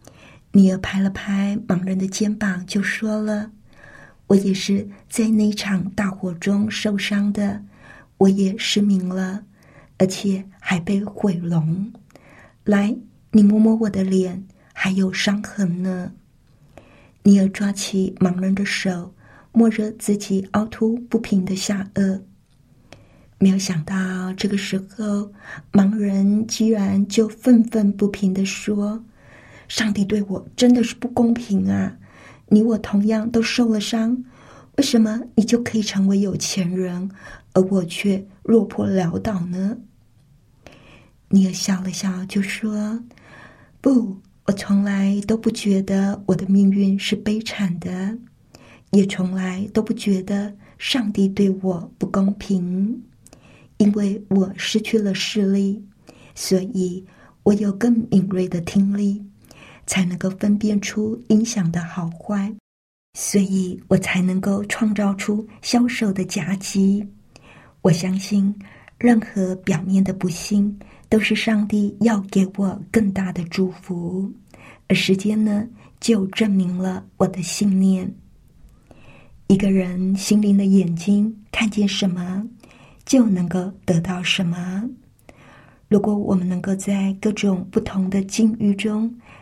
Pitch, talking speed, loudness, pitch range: 200 Hz, 185 characters per minute, -20 LUFS, 190-210 Hz